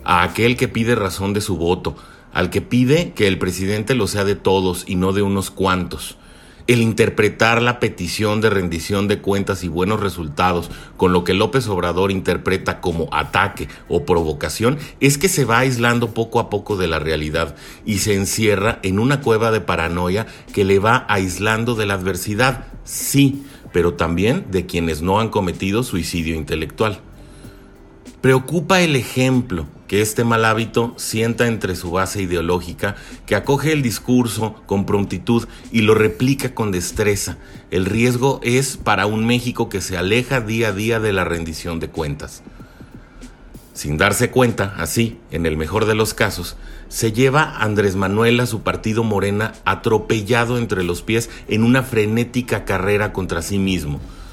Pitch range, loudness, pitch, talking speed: 90-115 Hz, -18 LUFS, 105 Hz, 165 wpm